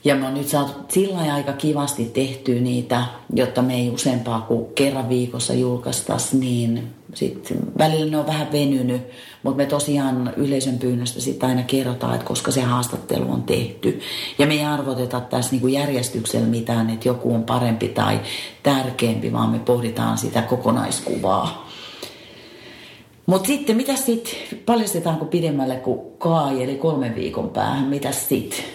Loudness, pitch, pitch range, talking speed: -21 LUFS, 130 Hz, 120-145 Hz, 150 wpm